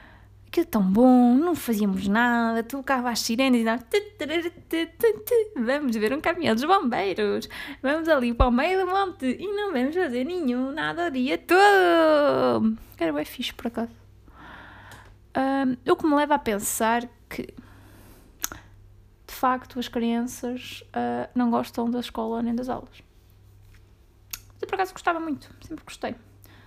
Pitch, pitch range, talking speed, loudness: 250 Hz, 225-320 Hz, 155 wpm, -24 LUFS